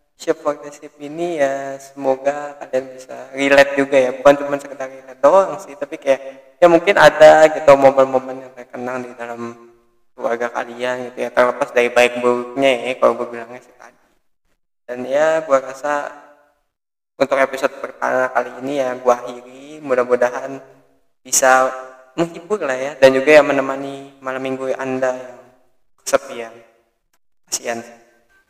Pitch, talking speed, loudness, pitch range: 130 Hz, 145 wpm, -16 LUFS, 125-140 Hz